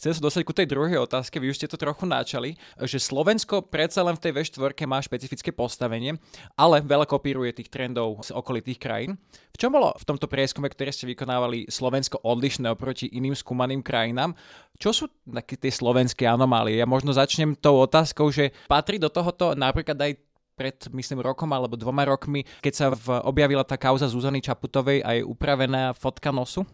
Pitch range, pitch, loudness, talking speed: 125-150 Hz, 135 Hz, -25 LUFS, 185 wpm